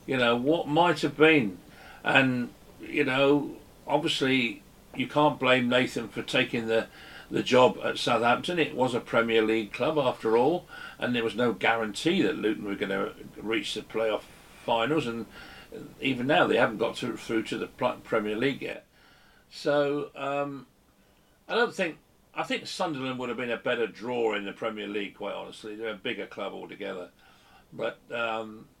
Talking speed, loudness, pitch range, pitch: 175 wpm, -27 LUFS, 110-145 Hz, 125 Hz